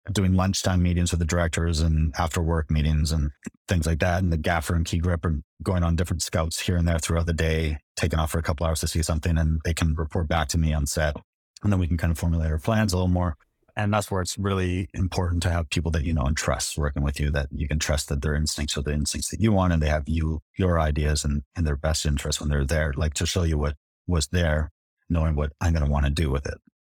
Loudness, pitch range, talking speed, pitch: -25 LUFS, 75-90 Hz, 275 wpm, 80 Hz